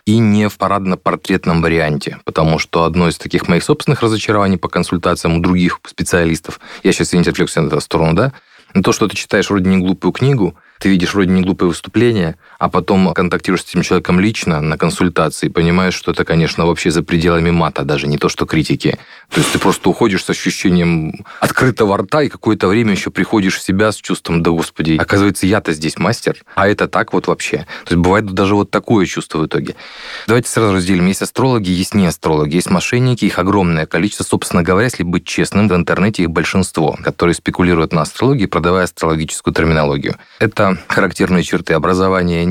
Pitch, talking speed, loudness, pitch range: 90 Hz, 190 wpm, -14 LUFS, 85-100 Hz